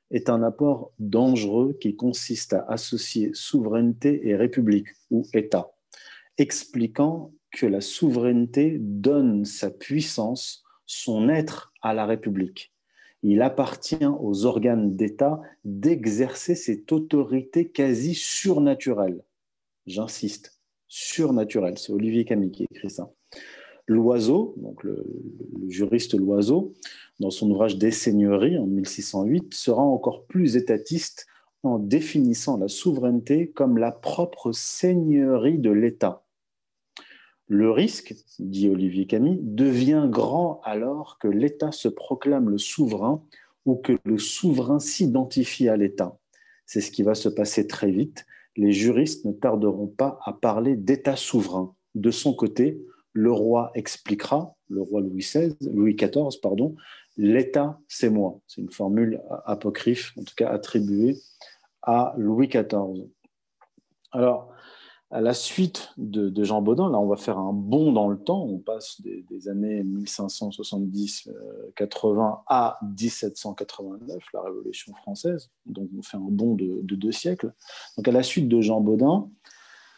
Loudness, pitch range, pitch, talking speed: -24 LUFS, 105-140 Hz, 115 Hz, 130 wpm